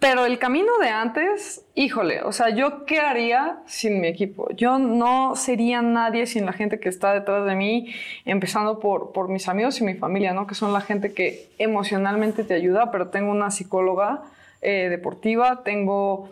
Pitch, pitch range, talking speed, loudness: 215 Hz, 195-245 Hz, 185 wpm, -22 LUFS